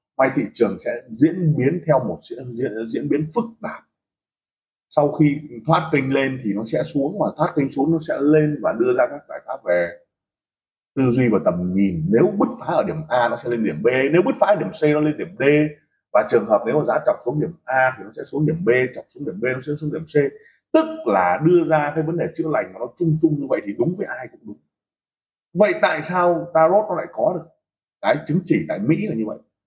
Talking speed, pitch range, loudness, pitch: 255 wpm, 130-160 Hz, -20 LUFS, 150 Hz